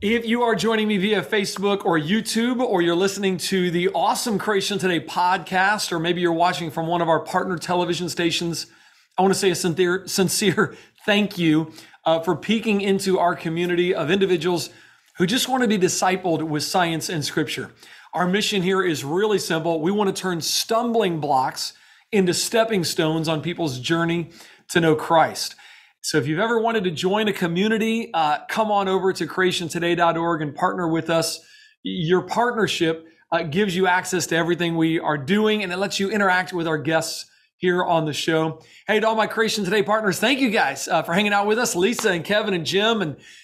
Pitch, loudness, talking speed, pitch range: 180 Hz, -21 LUFS, 195 wpm, 165-205 Hz